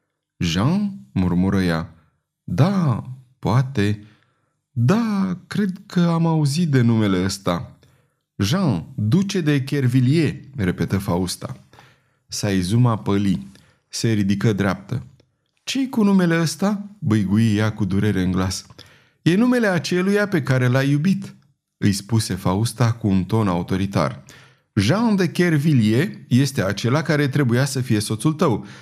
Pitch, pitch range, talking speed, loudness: 130 Hz, 105-165 Hz, 125 wpm, -20 LUFS